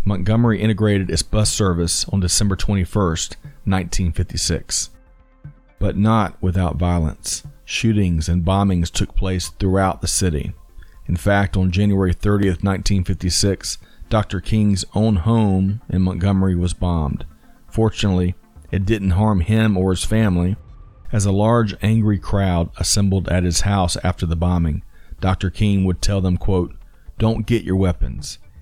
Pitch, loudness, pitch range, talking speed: 95 Hz, -19 LUFS, 90-105 Hz, 135 wpm